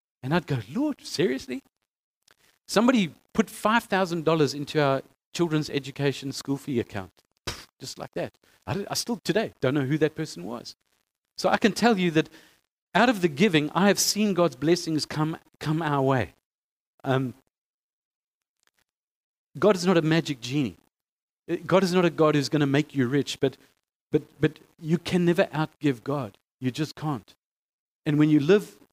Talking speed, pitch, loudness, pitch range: 170 wpm, 155 Hz, -25 LUFS, 140-180 Hz